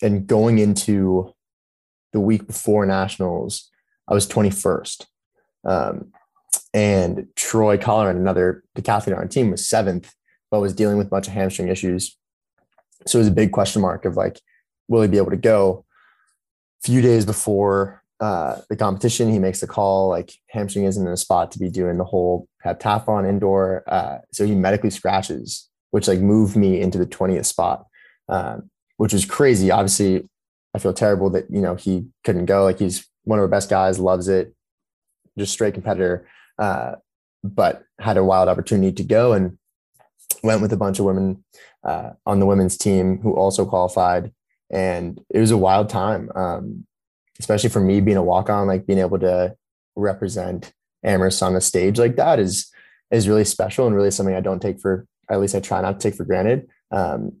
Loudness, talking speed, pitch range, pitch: -20 LUFS, 185 wpm, 95-105 Hz, 95 Hz